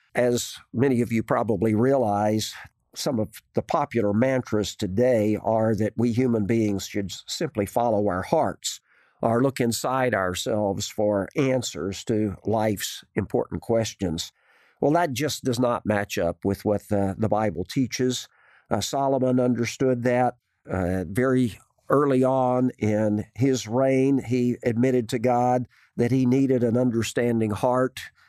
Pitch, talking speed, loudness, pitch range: 120 Hz, 140 wpm, -24 LUFS, 105-125 Hz